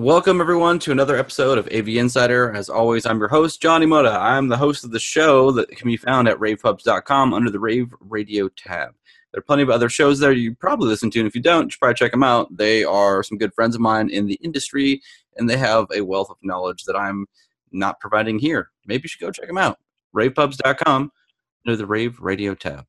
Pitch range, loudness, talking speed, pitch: 110-140 Hz, -19 LUFS, 230 wpm, 120 Hz